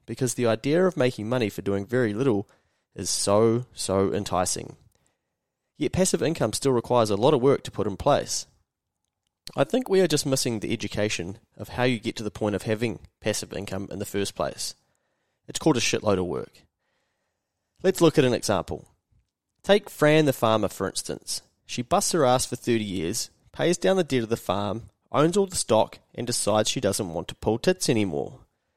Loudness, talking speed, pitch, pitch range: -25 LUFS, 195 wpm, 115 Hz, 100-135 Hz